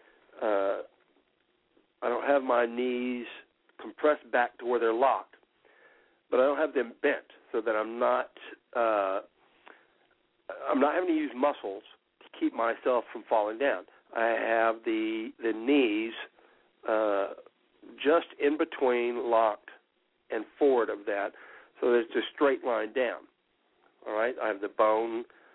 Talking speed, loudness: 145 wpm, -29 LUFS